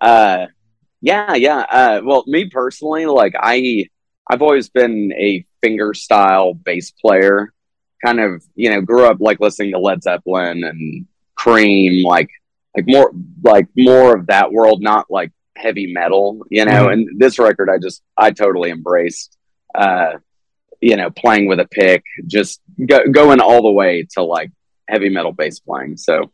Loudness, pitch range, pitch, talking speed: -13 LUFS, 95-130 Hz, 110 Hz, 165 wpm